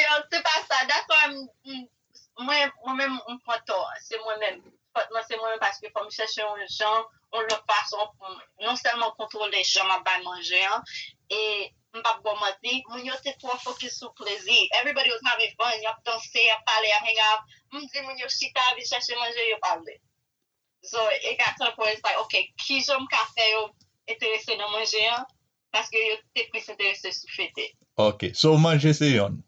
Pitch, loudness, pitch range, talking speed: 225 Hz, -24 LUFS, 210-250 Hz, 175 wpm